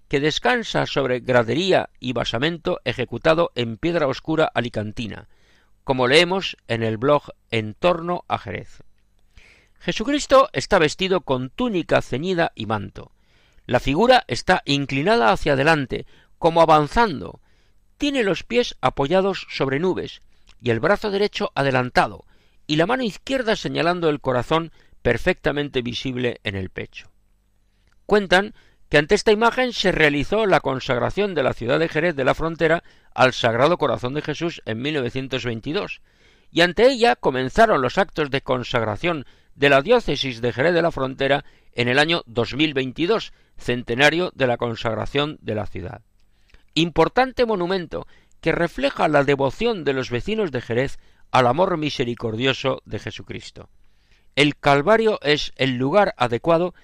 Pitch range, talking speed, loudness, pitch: 120-175 Hz, 140 wpm, -21 LUFS, 140 Hz